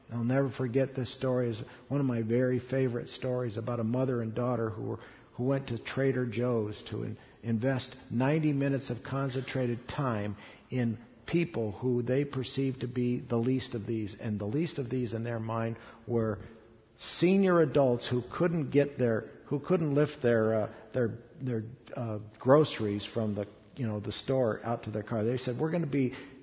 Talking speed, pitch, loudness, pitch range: 190 wpm, 125 Hz, -31 LUFS, 115-135 Hz